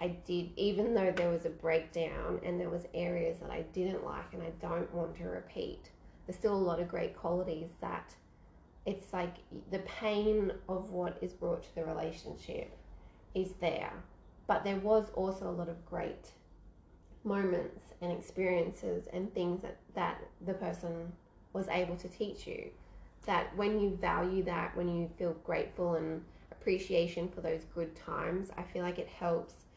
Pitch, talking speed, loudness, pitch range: 175 Hz, 170 wpm, -37 LUFS, 170-190 Hz